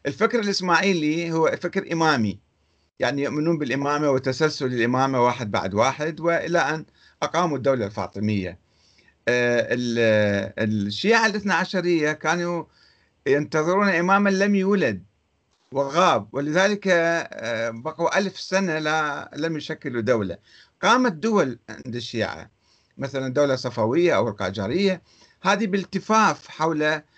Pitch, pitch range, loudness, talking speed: 150 Hz, 120-175 Hz, -22 LUFS, 110 wpm